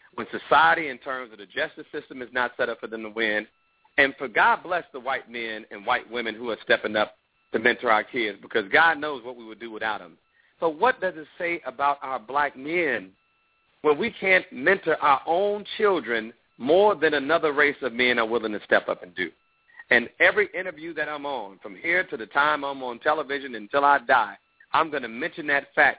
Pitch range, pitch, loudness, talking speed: 120-165 Hz, 140 Hz, -24 LUFS, 220 wpm